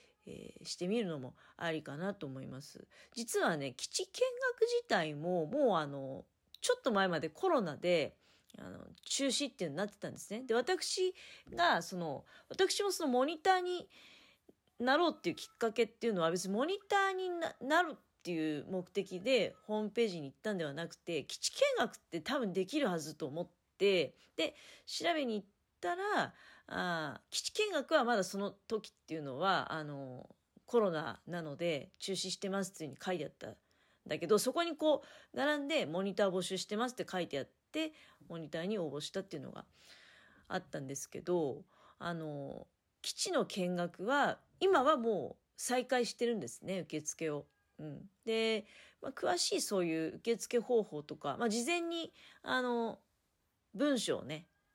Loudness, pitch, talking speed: -36 LUFS, 210 Hz, 330 characters per minute